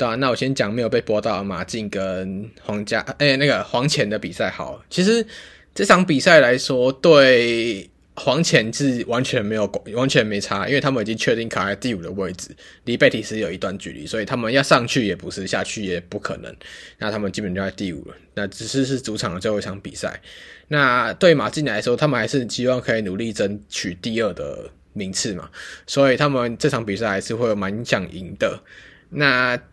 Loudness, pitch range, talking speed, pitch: -20 LUFS, 105-135 Hz, 305 characters per minute, 115 Hz